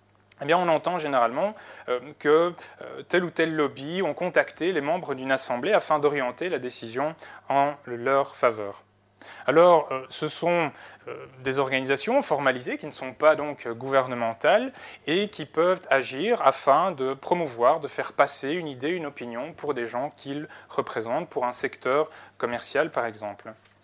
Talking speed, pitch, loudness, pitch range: 150 wpm, 140 Hz, -25 LUFS, 130-155 Hz